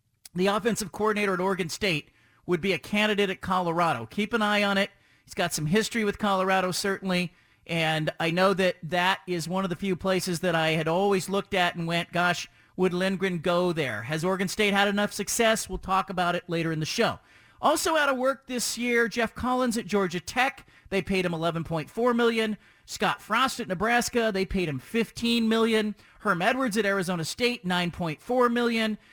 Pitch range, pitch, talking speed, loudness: 175-220 Hz, 195 Hz, 195 wpm, -26 LUFS